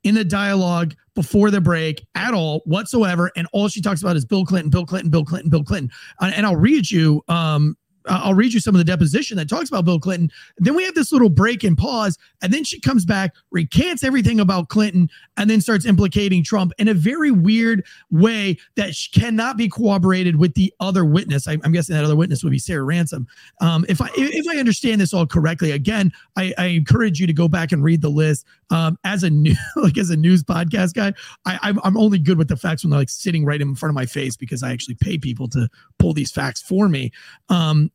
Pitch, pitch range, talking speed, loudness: 180 Hz, 160-205 Hz, 230 wpm, -18 LUFS